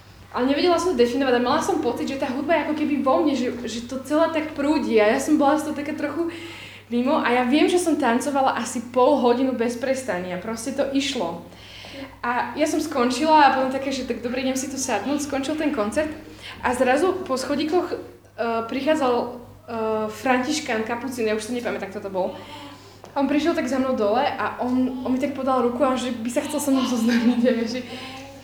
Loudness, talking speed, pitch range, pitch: -22 LUFS, 215 wpm, 240-290 Hz, 260 Hz